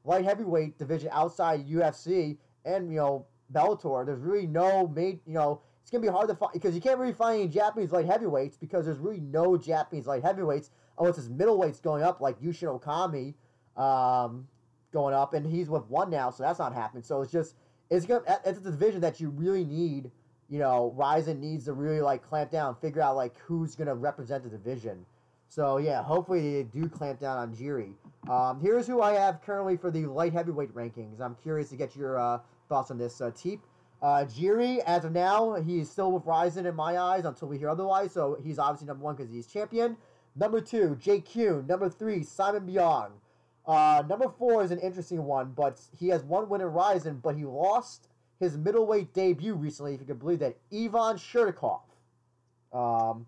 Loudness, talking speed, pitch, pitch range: -29 LUFS, 200 wpm, 155 Hz, 135-185 Hz